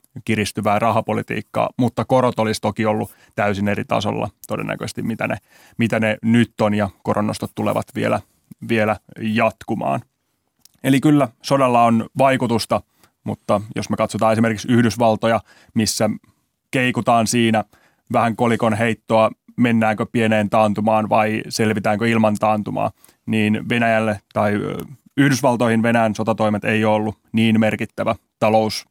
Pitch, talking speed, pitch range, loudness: 110 Hz, 120 wpm, 110-115 Hz, -19 LUFS